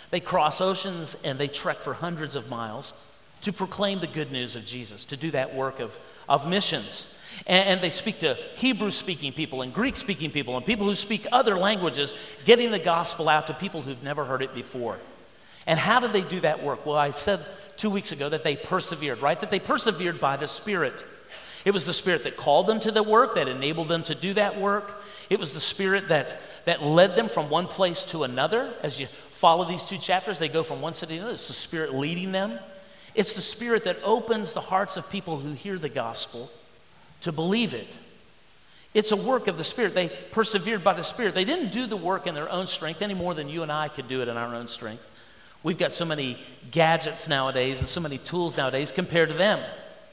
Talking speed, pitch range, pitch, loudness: 225 wpm, 150-200 Hz, 175 Hz, -26 LUFS